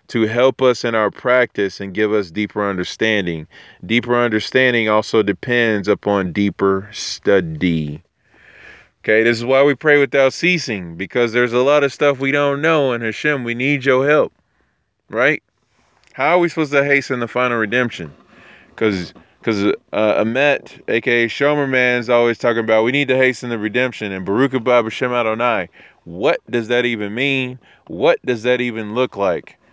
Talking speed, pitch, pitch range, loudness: 165 wpm, 120 Hz, 105-130 Hz, -17 LUFS